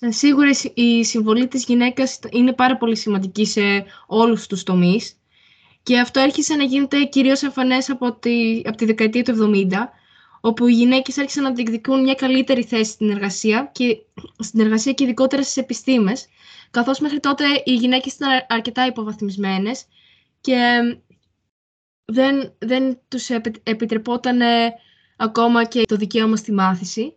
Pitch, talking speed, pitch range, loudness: 235 Hz, 140 wpm, 220-265 Hz, -18 LUFS